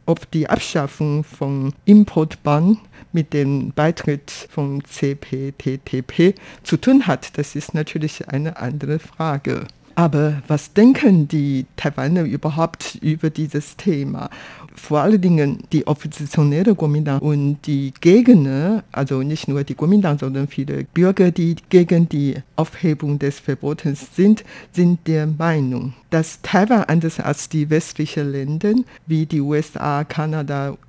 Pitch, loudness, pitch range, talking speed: 150 Hz, -18 LUFS, 140-170 Hz, 130 wpm